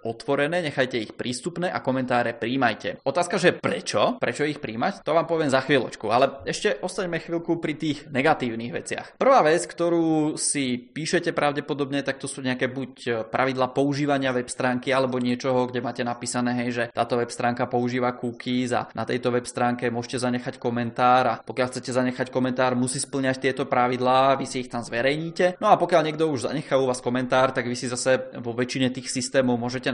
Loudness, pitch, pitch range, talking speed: -24 LUFS, 130 Hz, 125-145 Hz, 185 wpm